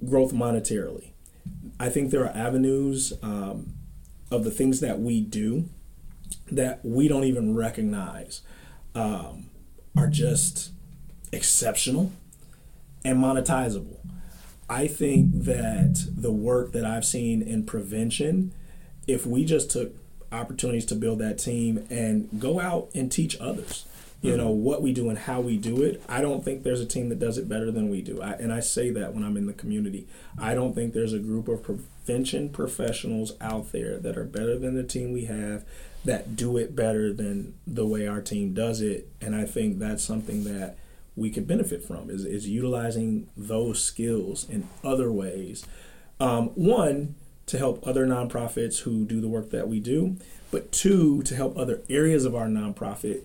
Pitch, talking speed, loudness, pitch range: 120 Hz, 170 wpm, -27 LUFS, 110-145 Hz